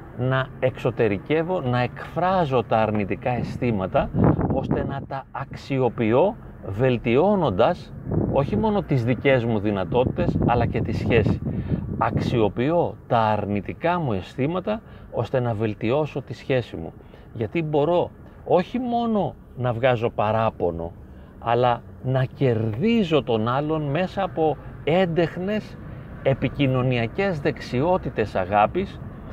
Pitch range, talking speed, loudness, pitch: 110-150 Hz, 105 wpm, -23 LUFS, 125 Hz